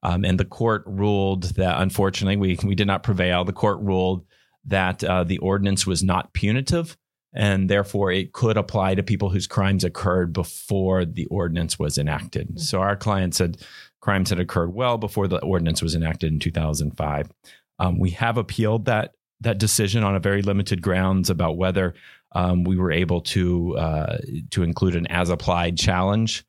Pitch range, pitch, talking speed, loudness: 90-100 Hz, 95 Hz, 175 wpm, -22 LUFS